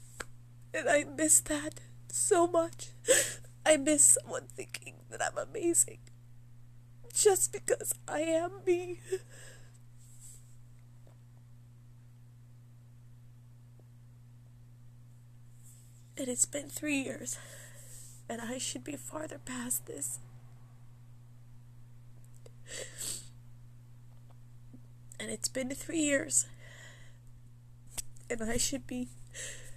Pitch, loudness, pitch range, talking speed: 120 Hz, -31 LUFS, 120-125 Hz, 80 wpm